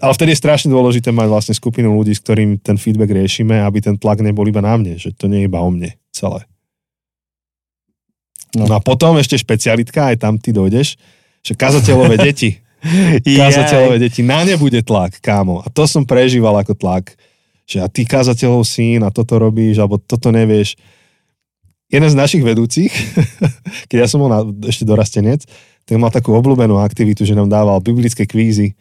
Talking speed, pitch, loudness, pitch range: 180 wpm, 115 Hz, -13 LUFS, 105-130 Hz